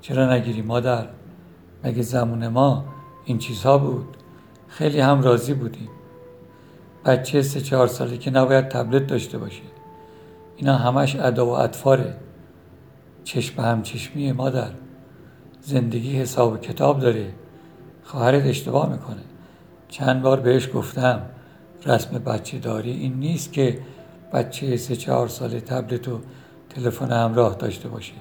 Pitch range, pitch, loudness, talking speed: 120-135 Hz, 130 Hz, -22 LUFS, 125 wpm